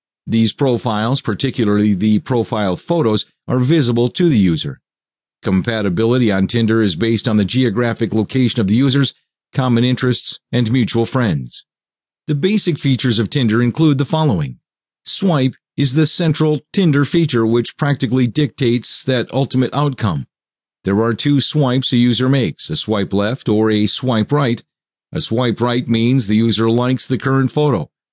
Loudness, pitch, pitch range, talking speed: -16 LUFS, 125 Hz, 110-140 Hz, 155 wpm